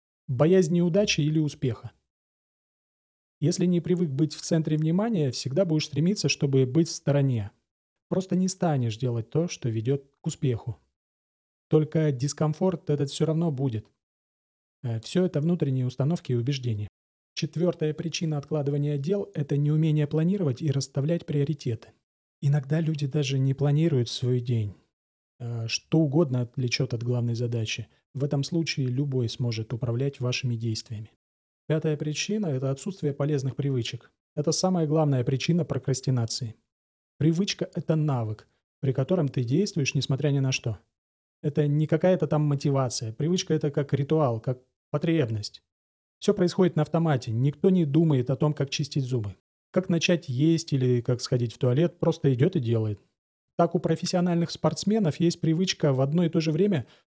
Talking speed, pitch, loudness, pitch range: 145 wpm, 145 Hz, -26 LUFS, 125-160 Hz